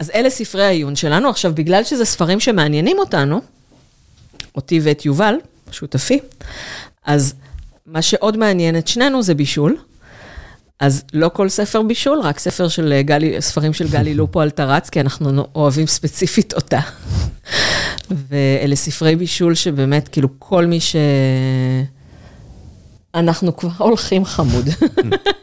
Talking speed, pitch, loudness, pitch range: 130 wpm, 165 Hz, -16 LUFS, 145-200 Hz